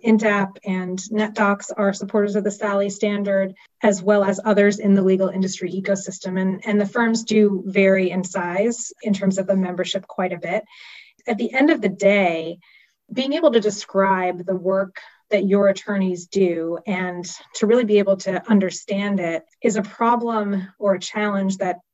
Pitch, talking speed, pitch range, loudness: 200 Hz, 180 wpm, 190-215 Hz, -20 LUFS